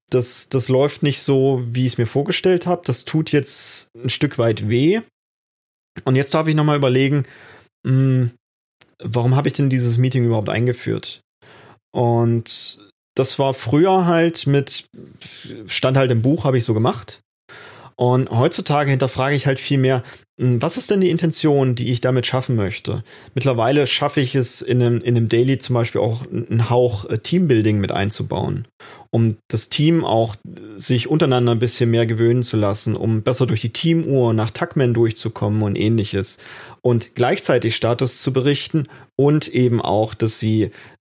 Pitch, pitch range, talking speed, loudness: 125 Hz, 115-140 Hz, 170 wpm, -19 LUFS